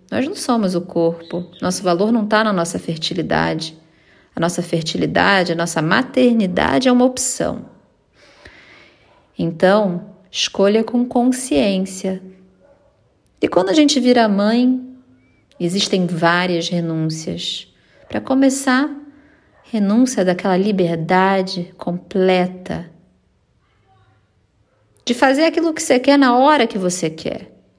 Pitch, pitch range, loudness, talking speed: 190 Hz, 170-245 Hz, -17 LUFS, 110 wpm